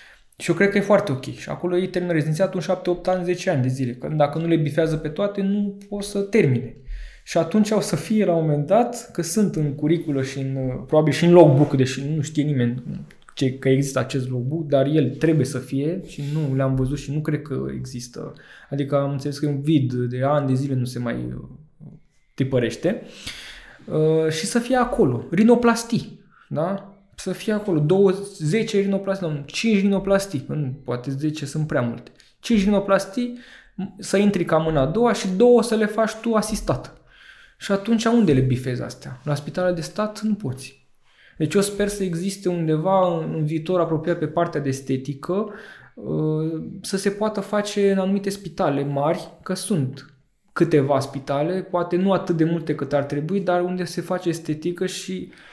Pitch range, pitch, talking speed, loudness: 140-195 Hz, 165 Hz, 190 wpm, -22 LUFS